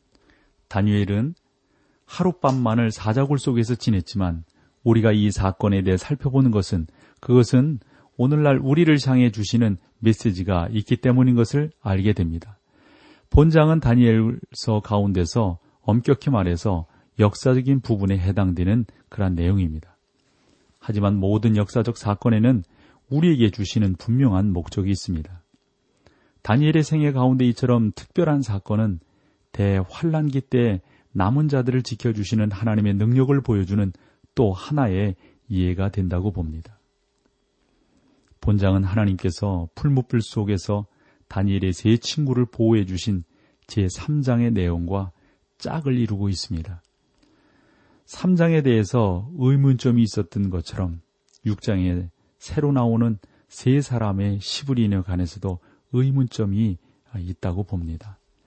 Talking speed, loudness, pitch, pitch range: 280 characters per minute, -21 LUFS, 110 Hz, 95-125 Hz